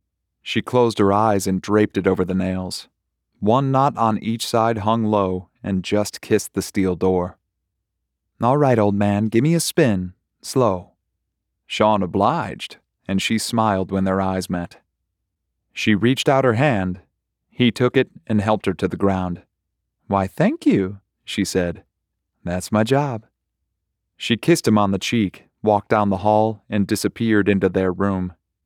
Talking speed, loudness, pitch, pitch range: 165 wpm, -20 LUFS, 100 Hz, 95-110 Hz